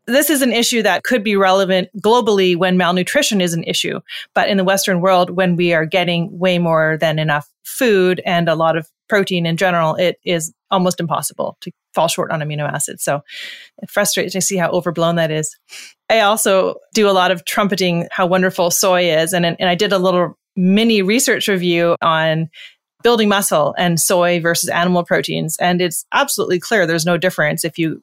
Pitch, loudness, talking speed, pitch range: 180 Hz, -16 LUFS, 195 wpm, 170-195 Hz